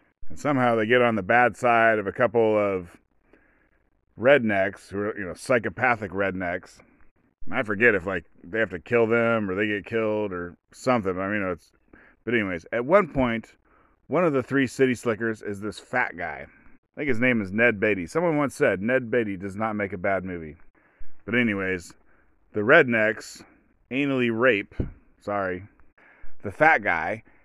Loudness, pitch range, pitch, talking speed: -24 LUFS, 100-120 Hz, 110 Hz, 175 wpm